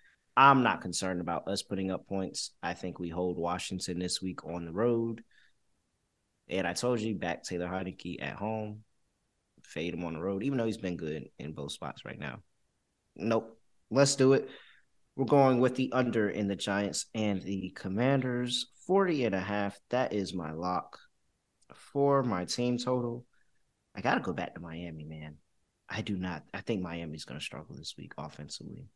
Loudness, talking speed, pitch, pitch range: -32 LUFS, 185 wpm, 95 Hz, 85-120 Hz